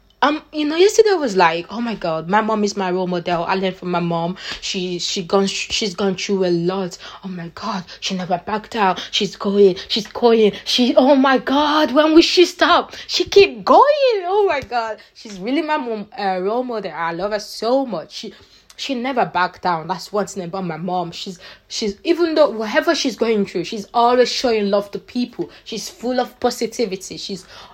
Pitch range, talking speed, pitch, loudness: 190-255 Hz, 205 wpm, 215 Hz, -18 LUFS